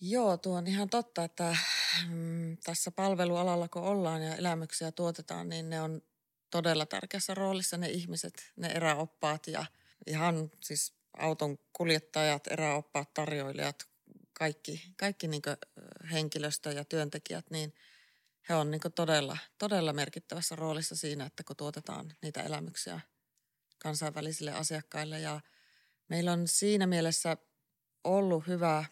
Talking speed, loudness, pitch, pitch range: 120 wpm, -34 LUFS, 160 Hz, 150-175 Hz